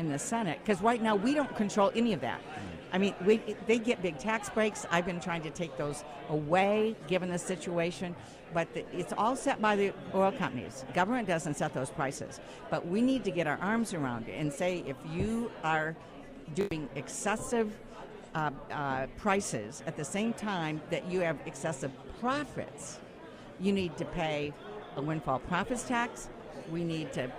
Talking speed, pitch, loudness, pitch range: 180 wpm, 175 Hz, -33 LUFS, 150-210 Hz